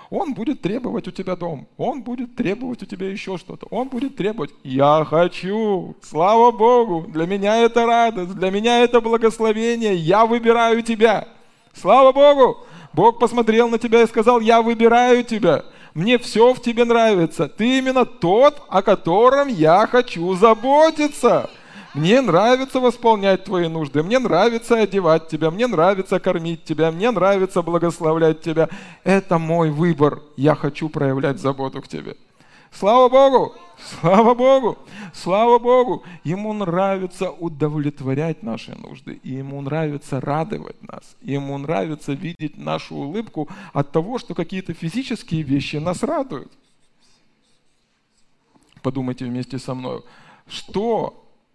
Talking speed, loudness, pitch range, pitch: 135 wpm, -18 LUFS, 160-235 Hz, 195 Hz